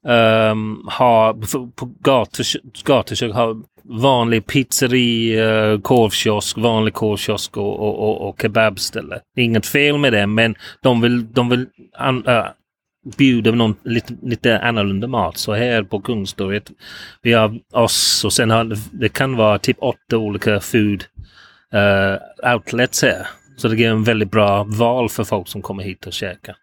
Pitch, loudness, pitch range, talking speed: 110 Hz, -17 LUFS, 105-120 Hz, 160 wpm